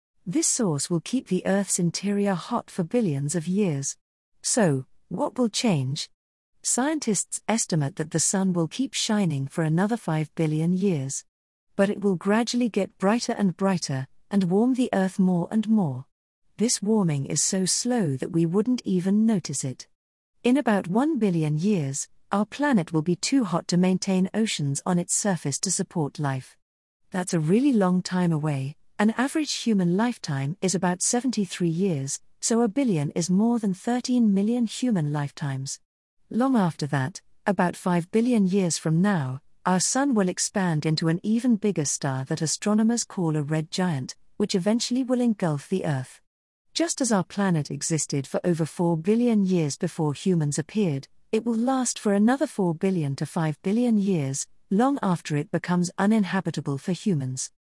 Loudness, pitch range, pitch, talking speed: -25 LUFS, 160-220 Hz, 185 Hz, 165 wpm